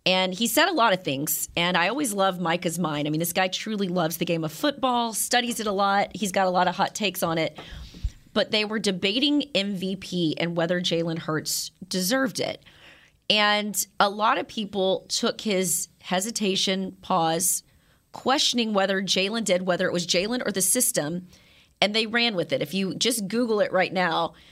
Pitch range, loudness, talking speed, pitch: 175-215 Hz, -24 LUFS, 195 wpm, 190 Hz